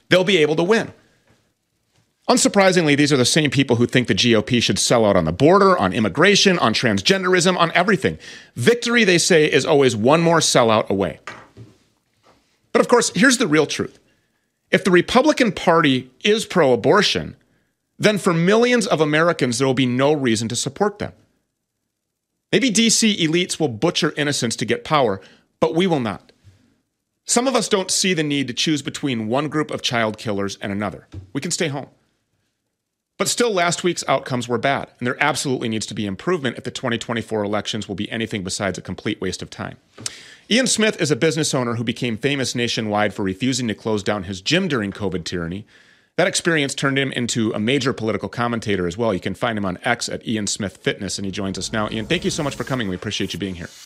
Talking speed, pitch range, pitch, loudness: 205 wpm, 110-170 Hz, 130 Hz, -19 LUFS